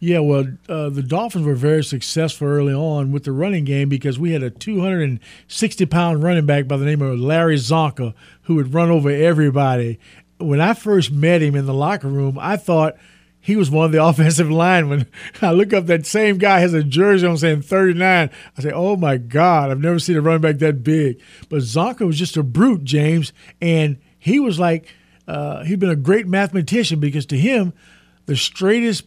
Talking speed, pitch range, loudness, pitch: 200 wpm, 145-180 Hz, -17 LUFS, 160 Hz